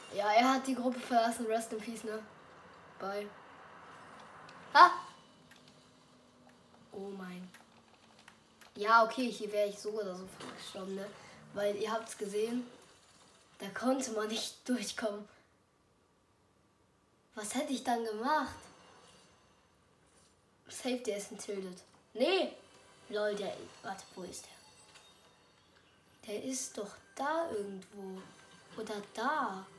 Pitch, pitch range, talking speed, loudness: 215 Hz, 195-230 Hz, 110 wpm, -34 LUFS